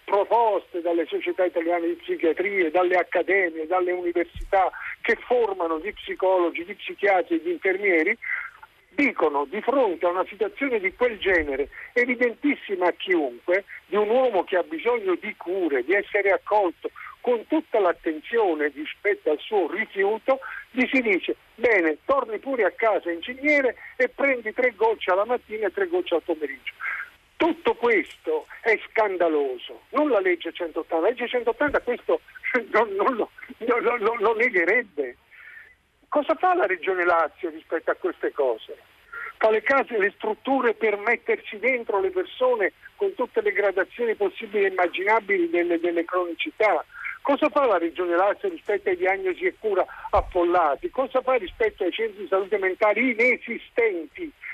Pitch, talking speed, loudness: 260 Hz, 145 wpm, -24 LUFS